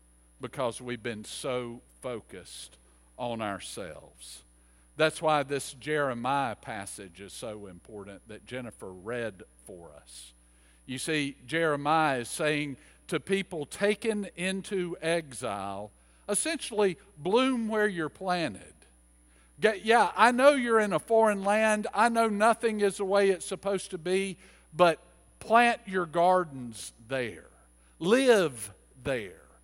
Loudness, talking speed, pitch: -28 LUFS, 125 wpm, 150 Hz